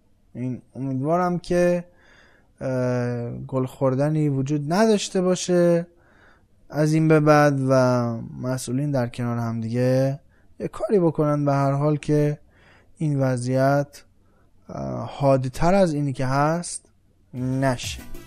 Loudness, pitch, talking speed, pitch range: -22 LUFS, 135 Hz, 110 wpm, 120-150 Hz